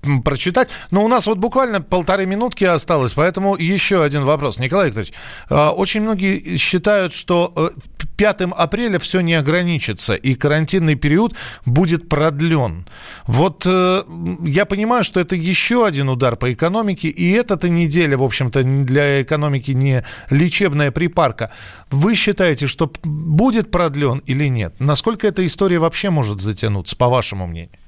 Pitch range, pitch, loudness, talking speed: 135-190 Hz, 160 Hz, -16 LUFS, 140 wpm